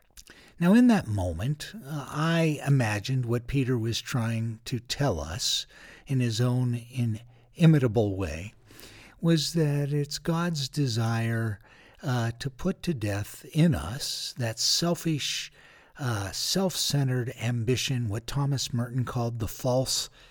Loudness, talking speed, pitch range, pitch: -27 LUFS, 125 wpm, 115-145 Hz, 125 Hz